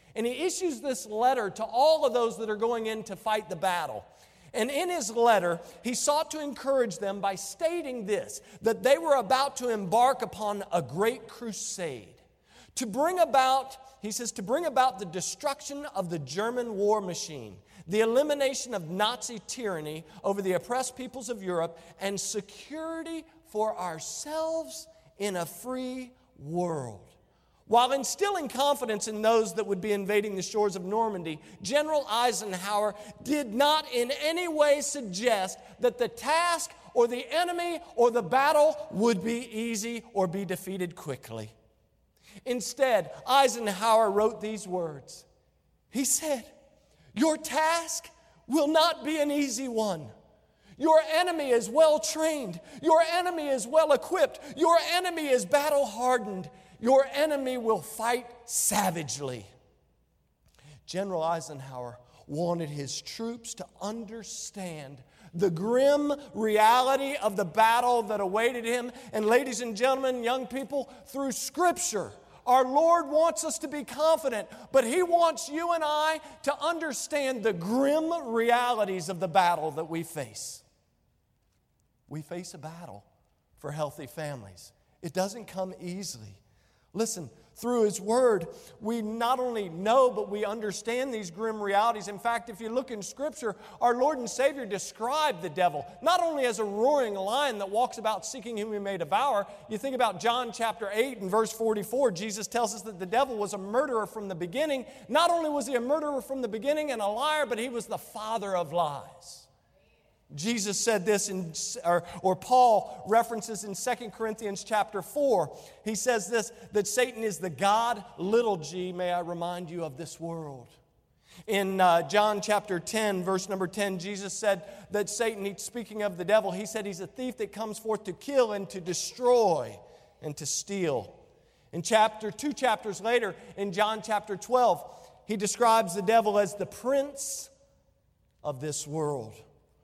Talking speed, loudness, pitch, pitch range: 155 wpm, -28 LUFS, 225 Hz, 190-265 Hz